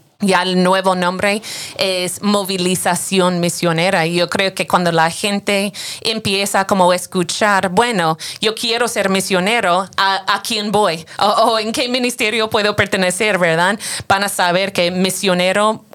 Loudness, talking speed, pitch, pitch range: -15 LUFS, 150 wpm, 195 Hz, 180-210 Hz